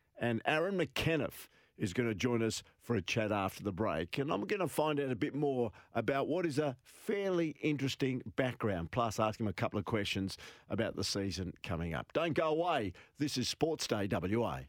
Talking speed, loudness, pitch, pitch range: 205 wpm, -35 LUFS, 120 Hz, 100-140 Hz